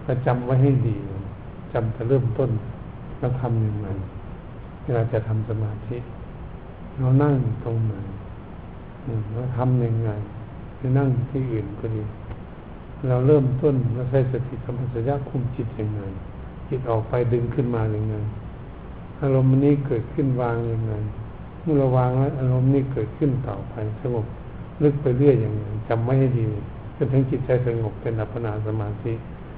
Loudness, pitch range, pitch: -23 LUFS, 110-130 Hz, 120 Hz